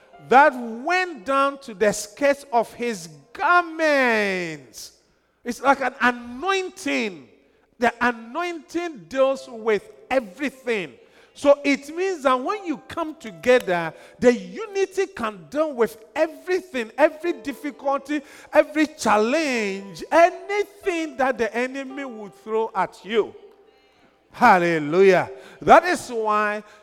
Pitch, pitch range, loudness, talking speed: 265 Hz, 225-320 Hz, -22 LUFS, 105 wpm